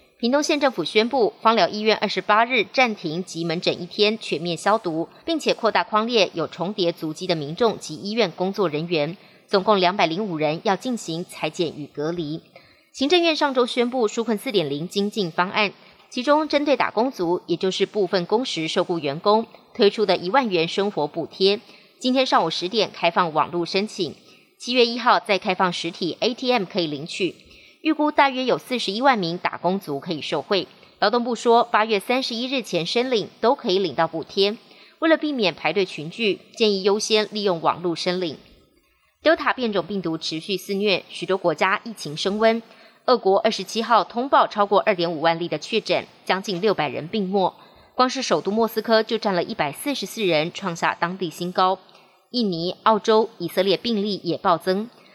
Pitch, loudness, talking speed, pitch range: 200 Hz, -22 LUFS, 295 characters per minute, 175-225 Hz